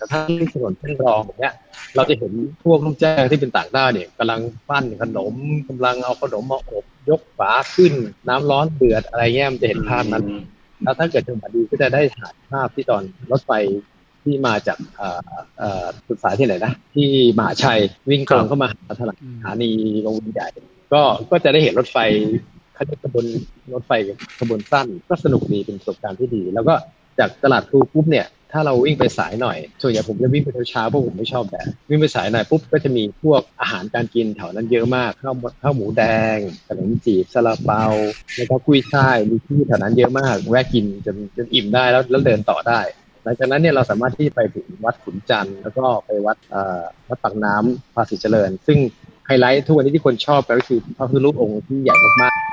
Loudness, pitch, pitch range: -18 LUFS, 125 Hz, 110-140 Hz